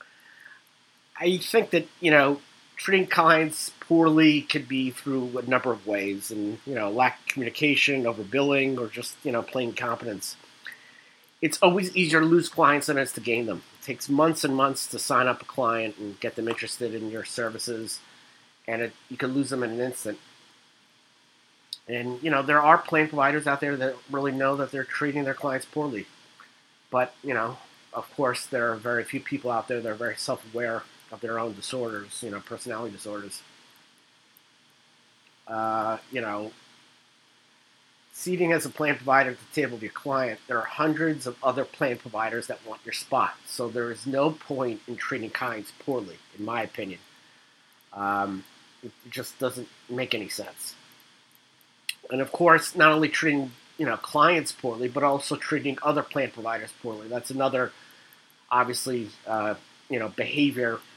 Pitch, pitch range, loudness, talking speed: 130 Hz, 115-145 Hz, -26 LUFS, 175 wpm